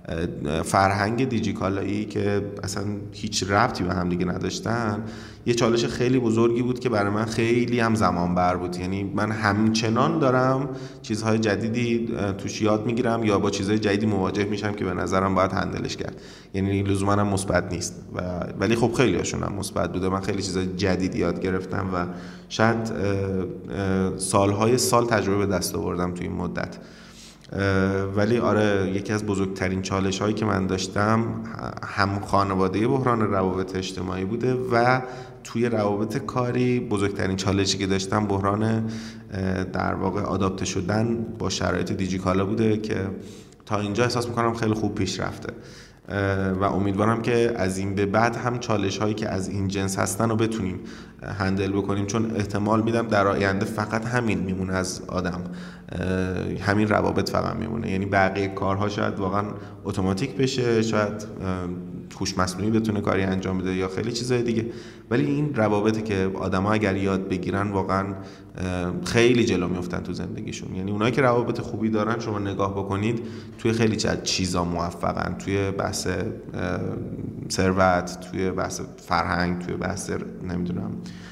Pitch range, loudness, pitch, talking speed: 95-110 Hz, -24 LUFS, 100 Hz, 150 wpm